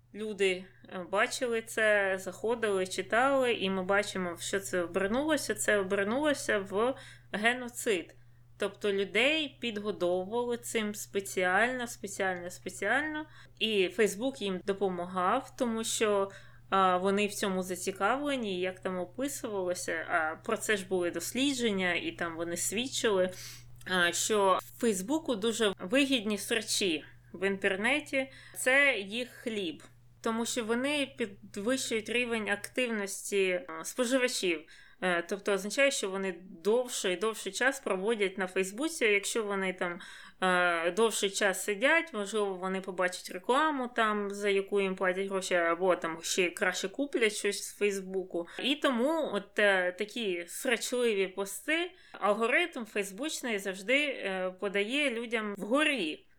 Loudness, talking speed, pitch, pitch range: -31 LUFS, 115 wpm, 205 Hz, 185-240 Hz